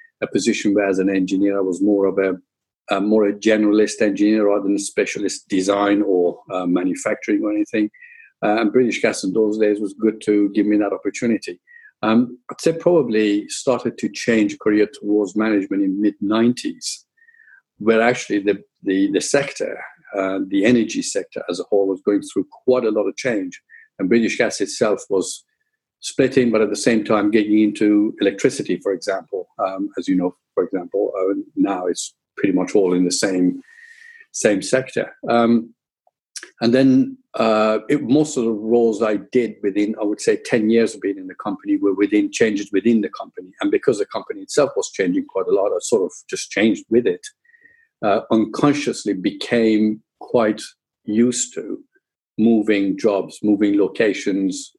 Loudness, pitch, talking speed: -19 LUFS, 115 Hz, 175 wpm